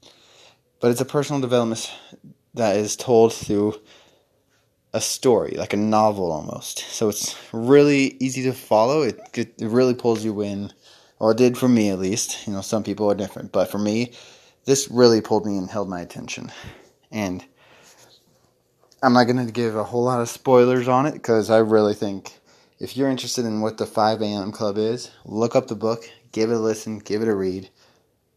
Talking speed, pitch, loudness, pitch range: 190 wpm, 110 Hz, -21 LUFS, 105-125 Hz